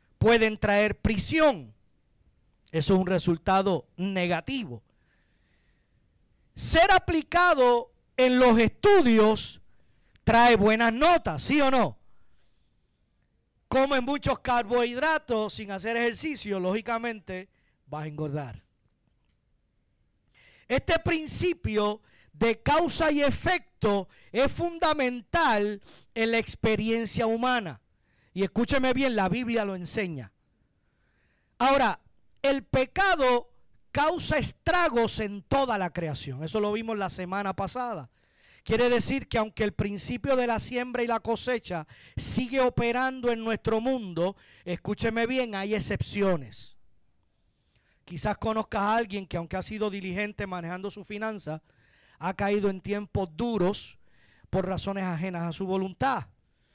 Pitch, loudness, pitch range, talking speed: 215 Hz, -26 LUFS, 185-250 Hz, 115 wpm